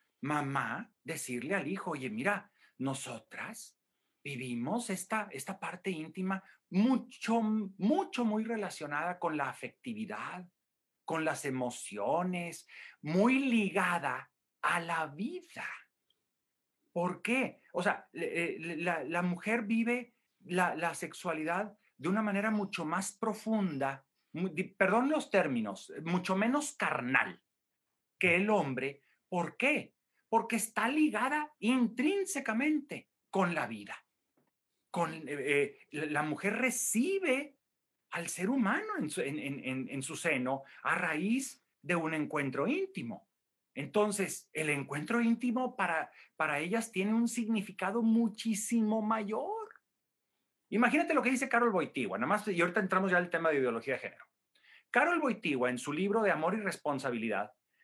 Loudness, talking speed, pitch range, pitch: -33 LUFS, 130 wpm, 160-230 Hz, 195 Hz